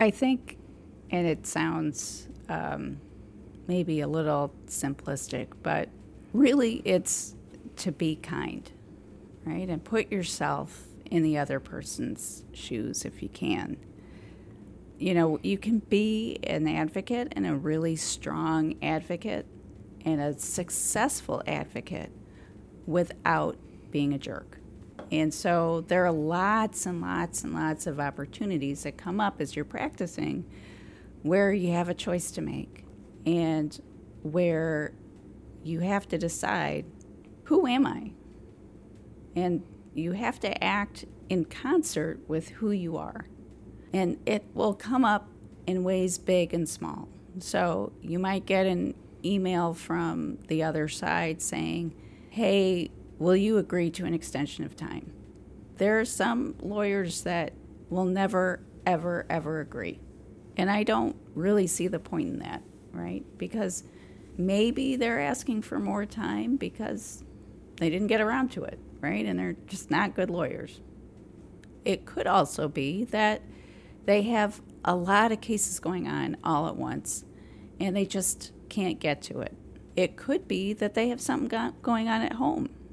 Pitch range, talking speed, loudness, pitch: 145-200 Hz, 145 wpm, -29 LUFS, 170 Hz